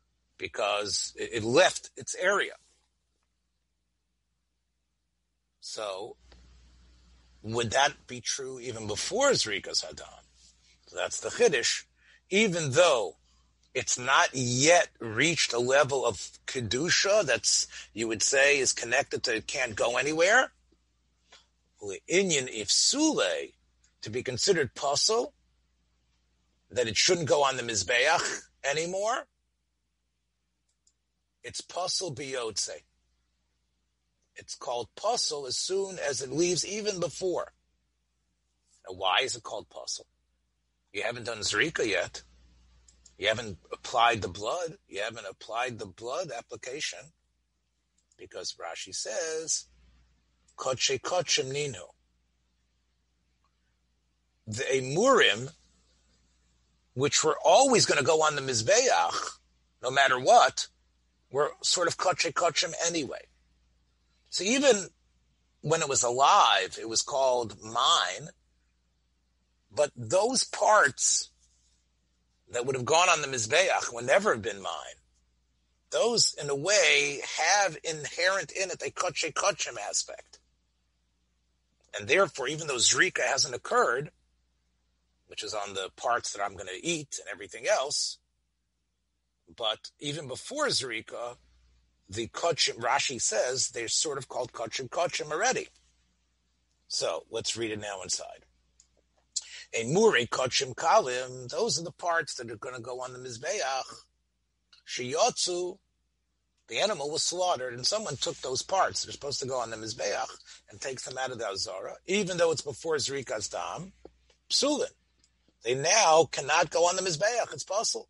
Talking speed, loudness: 125 wpm, -27 LUFS